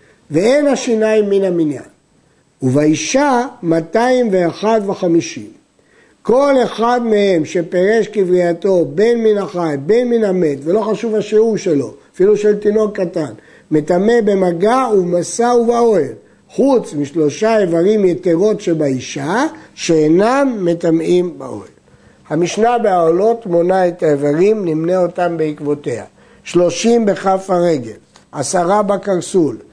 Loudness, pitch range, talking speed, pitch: -14 LUFS, 170-220 Hz, 100 wpm, 190 Hz